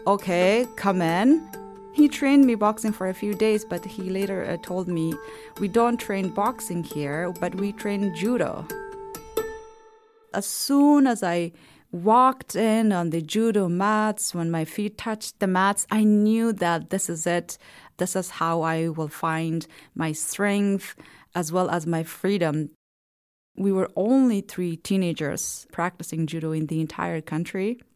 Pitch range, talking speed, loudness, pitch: 170-220 Hz, 155 wpm, -24 LUFS, 195 Hz